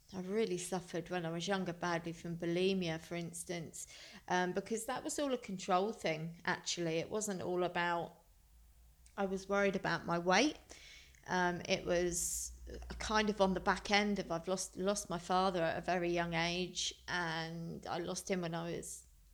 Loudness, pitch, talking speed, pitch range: -37 LUFS, 175 Hz, 180 wpm, 165-190 Hz